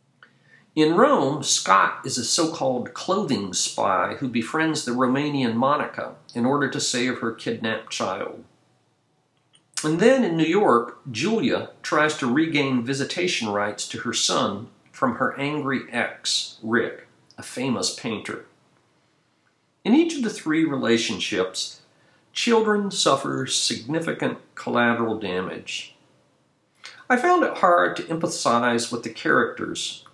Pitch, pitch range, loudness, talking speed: 140 Hz, 120-165 Hz, -23 LUFS, 125 wpm